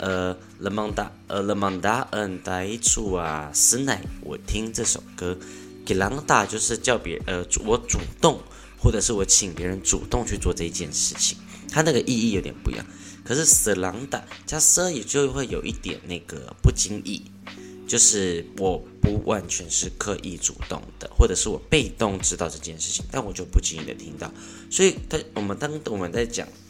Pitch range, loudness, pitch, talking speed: 90-110 Hz, -23 LUFS, 95 Hz, 260 characters per minute